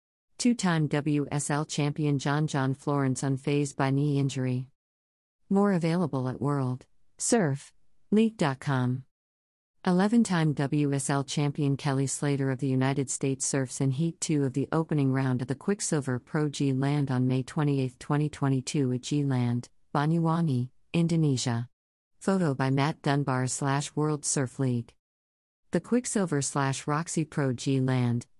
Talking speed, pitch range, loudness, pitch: 125 wpm, 130-150 Hz, -28 LUFS, 140 Hz